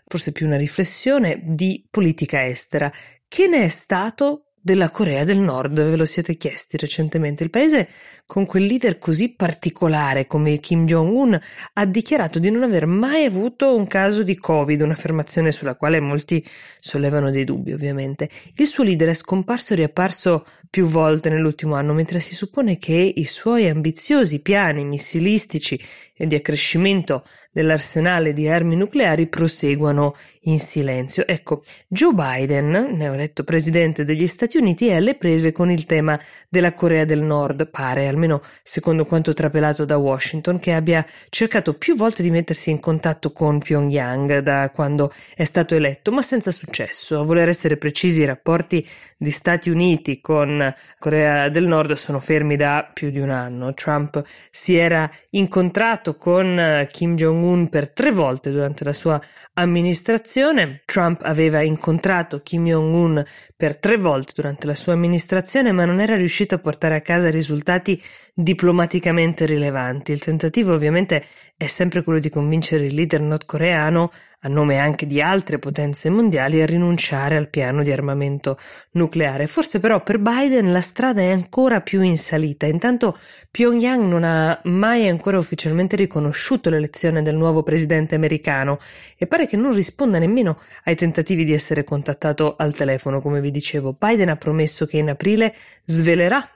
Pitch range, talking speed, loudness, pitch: 150-185 Hz, 155 wpm, -19 LUFS, 165 Hz